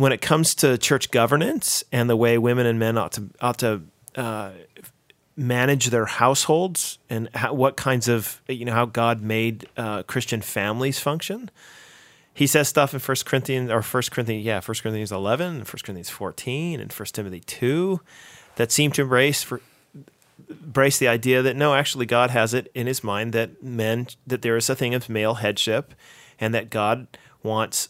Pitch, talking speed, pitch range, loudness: 125 Hz, 185 wpm, 115-135 Hz, -22 LUFS